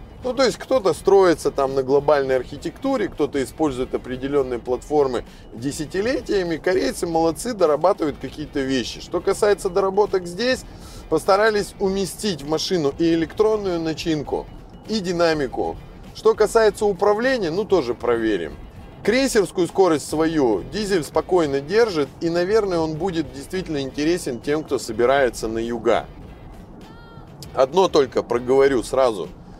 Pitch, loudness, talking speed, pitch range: 165 Hz, -21 LUFS, 120 wpm, 140-195 Hz